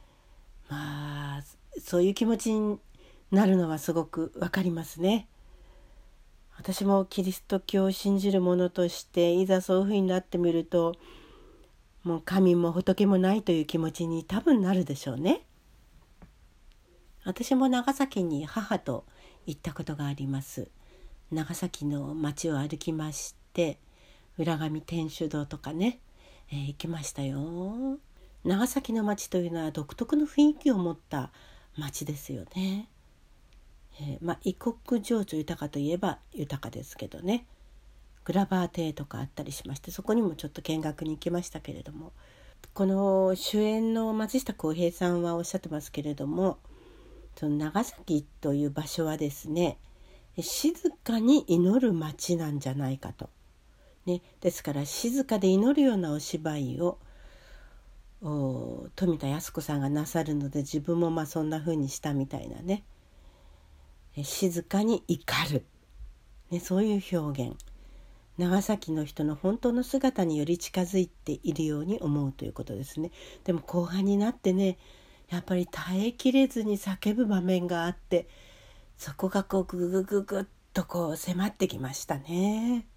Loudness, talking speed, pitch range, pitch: -29 LUFS, 280 characters per minute, 150-195 Hz, 170 Hz